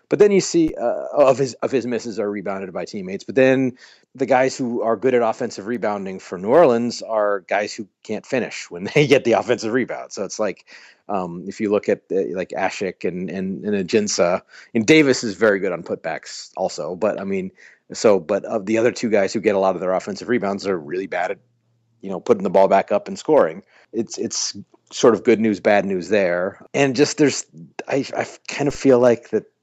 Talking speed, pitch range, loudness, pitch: 225 wpm, 105-140 Hz, -20 LUFS, 120 Hz